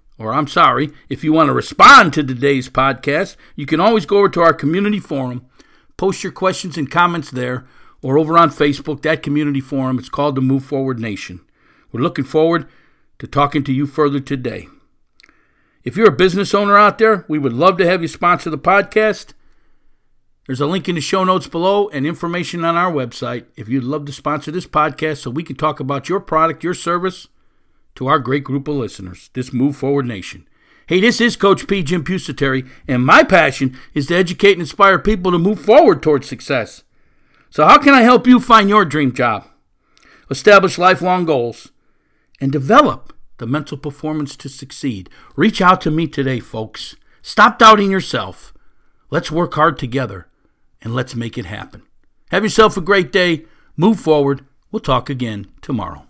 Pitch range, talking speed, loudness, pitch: 135-185 Hz, 185 wpm, -15 LUFS, 150 Hz